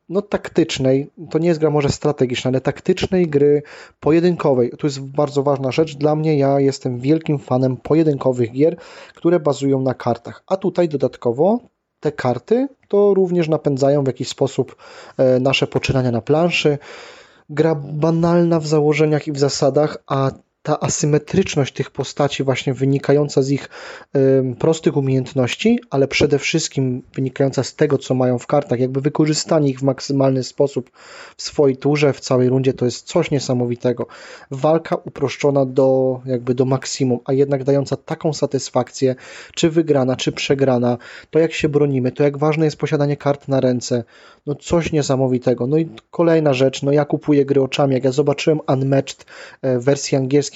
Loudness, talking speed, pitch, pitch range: -18 LUFS, 160 wpm, 140 Hz, 130-155 Hz